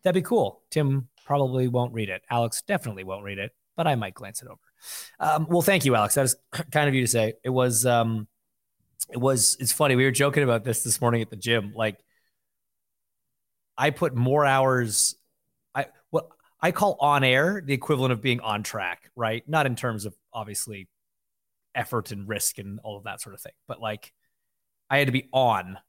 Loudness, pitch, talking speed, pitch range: -24 LUFS, 125 Hz, 210 wpm, 110-140 Hz